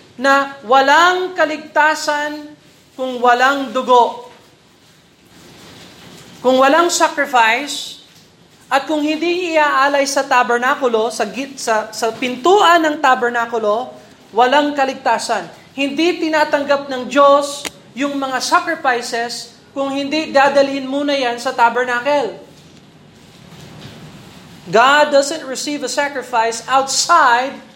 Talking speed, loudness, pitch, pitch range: 95 wpm, -15 LUFS, 275 Hz, 245-295 Hz